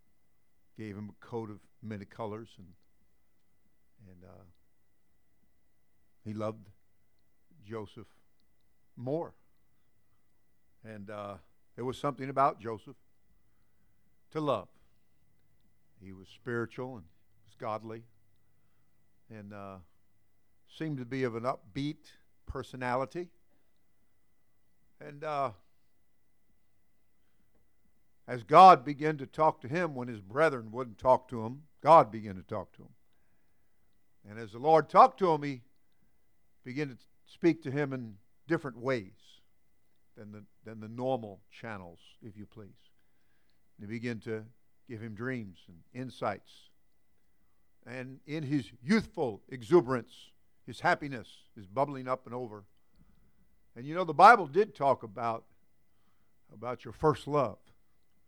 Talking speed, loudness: 120 wpm, -30 LUFS